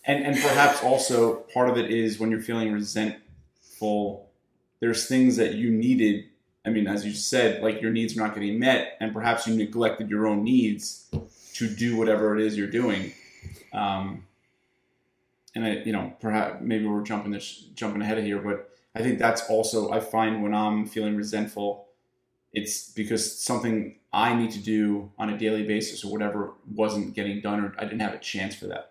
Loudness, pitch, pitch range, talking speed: -26 LUFS, 110 Hz, 105-115 Hz, 190 wpm